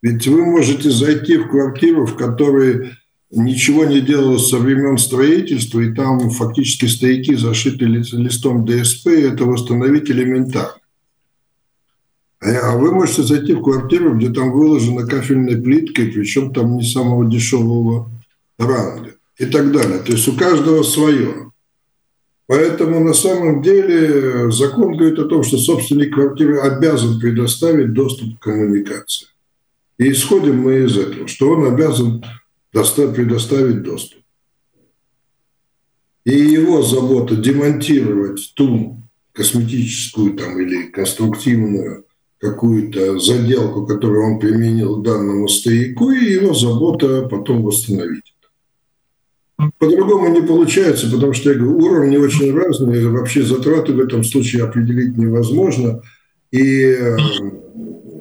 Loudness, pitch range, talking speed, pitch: -14 LUFS, 115-145 Hz, 120 wpm, 130 Hz